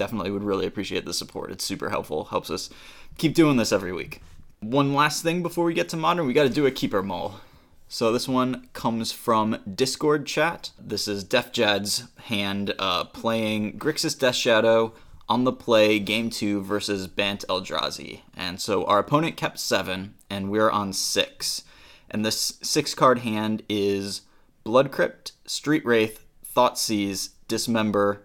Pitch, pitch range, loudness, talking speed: 110 Hz, 100-130 Hz, -24 LUFS, 165 wpm